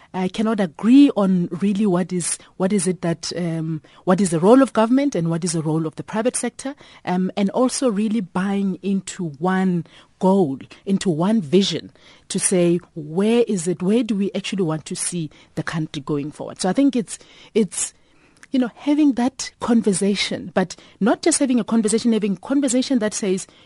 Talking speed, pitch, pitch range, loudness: 190 wpm, 195 Hz, 175-230 Hz, -20 LUFS